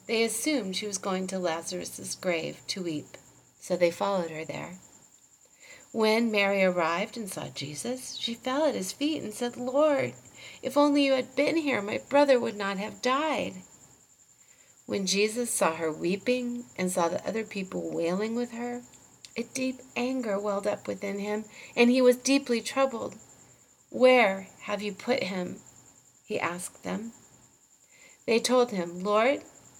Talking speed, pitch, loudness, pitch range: 155 wpm, 220 Hz, -28 LUFS, 185-255 Hz